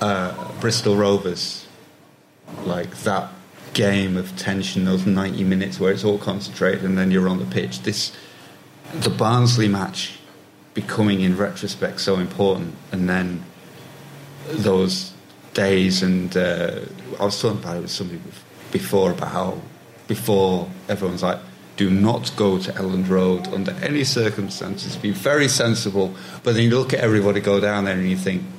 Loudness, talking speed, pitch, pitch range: -21 LUFS, 155 wpm, 95 Hz, 95-105 Hz